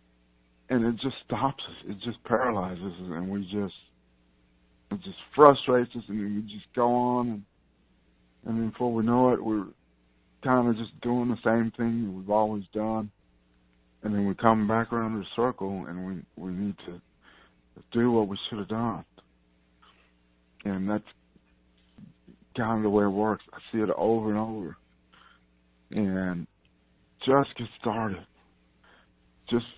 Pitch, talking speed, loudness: 100 Hz, 155 wpm, -28 LUFS